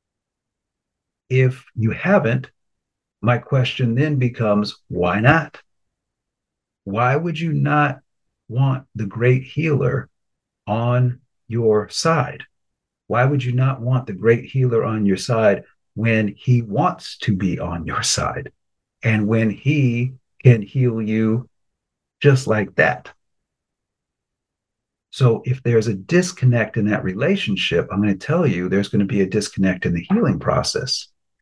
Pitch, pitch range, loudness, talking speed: 120 Hz, 105-130 Hz, -19 LUFS, 135 wpm